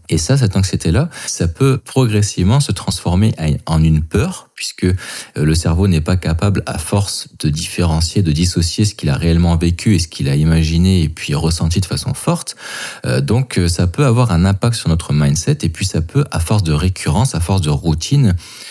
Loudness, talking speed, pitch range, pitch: -16 LUFS, 195 wpm, 80-105 Hz, 90 Hz